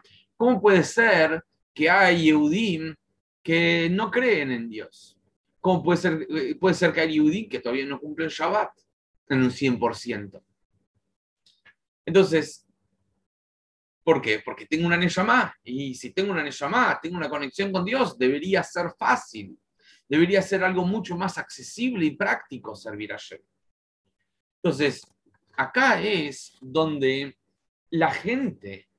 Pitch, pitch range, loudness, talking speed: 155 Hz, 120-180 Hz, -23 LUFS, 130 wpm